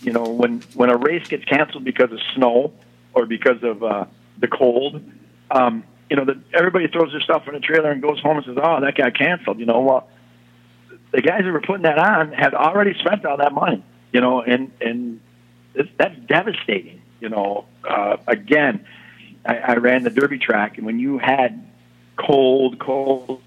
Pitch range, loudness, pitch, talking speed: 110-150 Hz, -19 LUFS, 130 Hz, 195 wpm